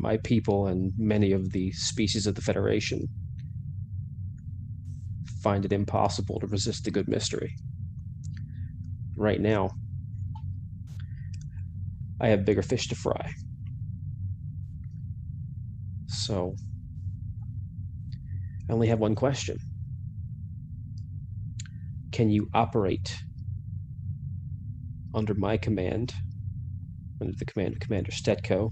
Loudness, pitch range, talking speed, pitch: -31 LUFS, 100-115 Hz, 90 wpm, 105 Hz